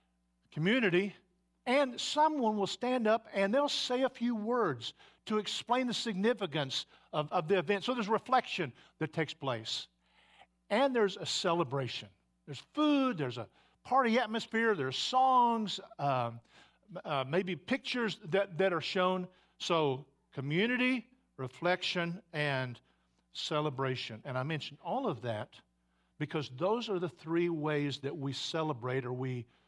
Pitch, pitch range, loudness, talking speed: 180 Hz, 135-225 Hz, -33 LUFS, 150 wpm